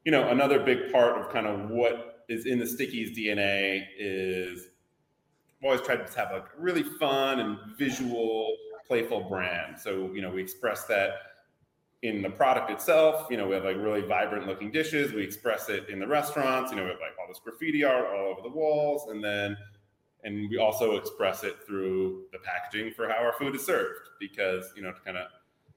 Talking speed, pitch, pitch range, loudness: 205 wpm, 105 Hz, 95-140 Hz, -29 LUFS